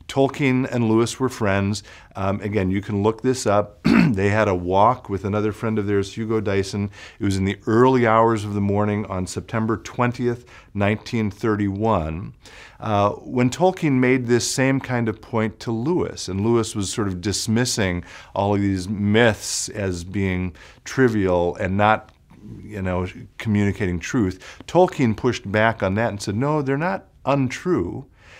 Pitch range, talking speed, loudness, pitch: 100-120 Hz, 165 wpm, -21 LUFS, 110 Hz